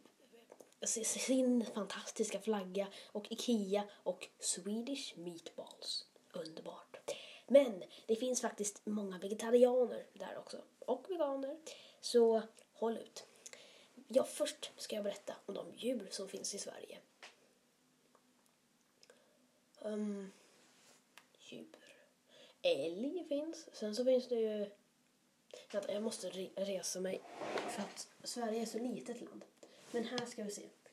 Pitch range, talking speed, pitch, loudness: 205-265 Hz, 115 wpm, 230 Hz, -39 LUFS